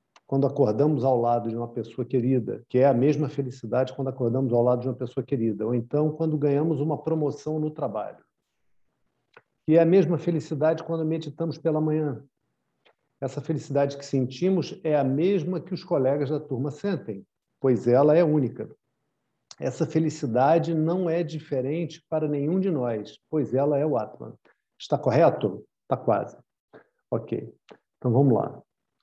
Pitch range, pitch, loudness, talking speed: 130-160 Hz, 145 Hz, -25 LUFS, 160 wpm